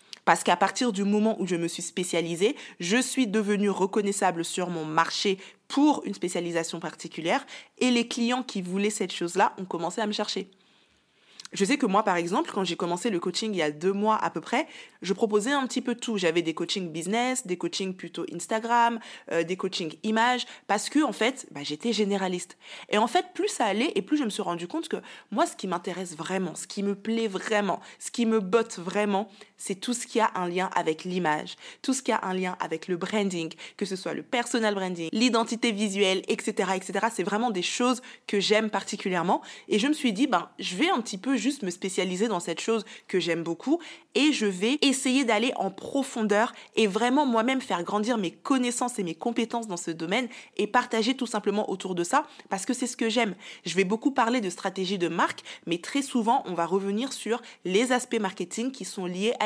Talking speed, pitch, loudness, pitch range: 220 wpm, 210 Hz, -27 LUFS, 185-240 Hz